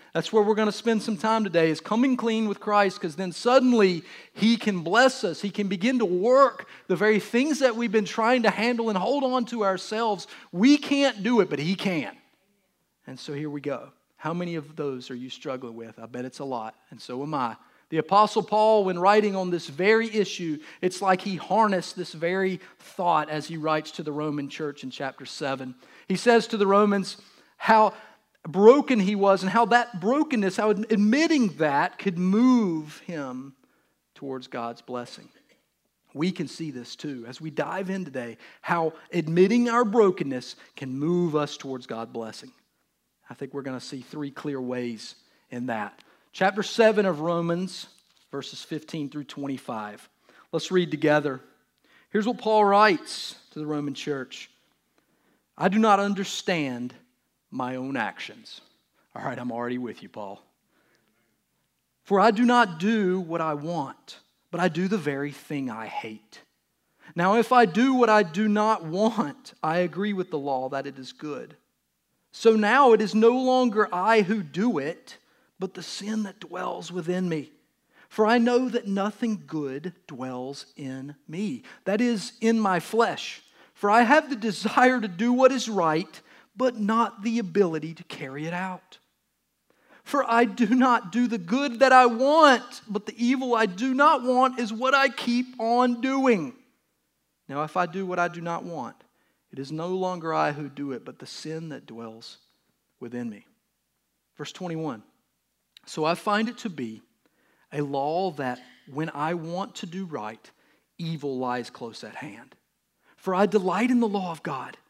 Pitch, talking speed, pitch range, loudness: 190 Hz, 180 wpm, 150-225 Hz, -24 LUFS